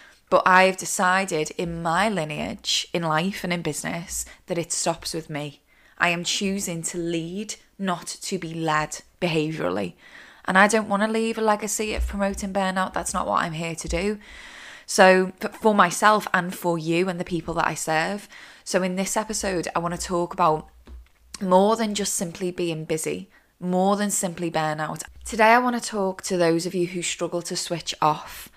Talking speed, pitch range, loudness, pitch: 190 wpm, 165-195 Hz, -23 LUFS, 180 Hz